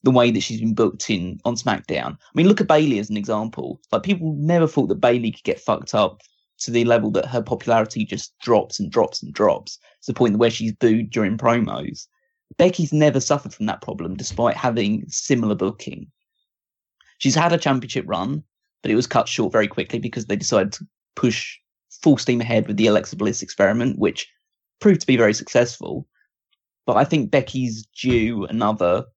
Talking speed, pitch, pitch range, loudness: 195 wpm, 120 Hz, 110-150 Hz, -20 LUFS